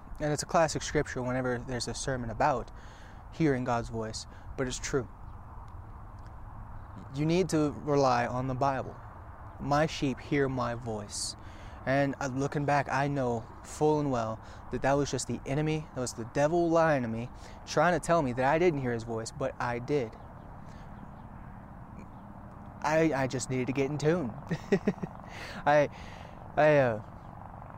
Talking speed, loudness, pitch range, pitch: 160 wpm, -30 LUFS, 105-145 Hz, 125 Hz